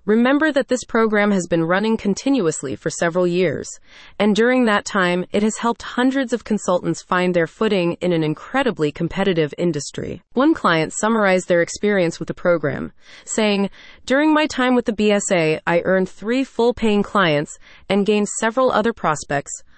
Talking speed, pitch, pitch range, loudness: 165 wpm, 200 Hz, 170-230 Hz, -19 LUFS